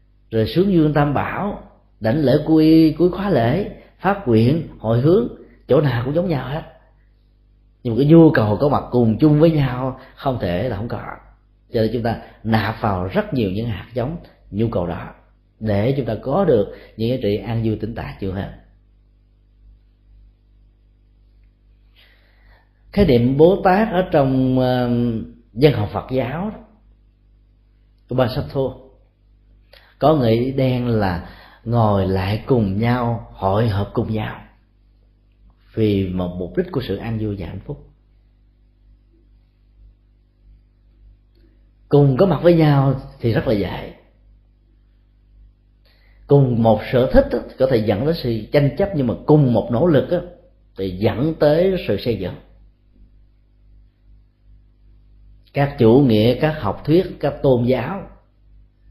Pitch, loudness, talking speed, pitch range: 115 Hz, -18 LUFS, 145 wpm, 105-130 Hz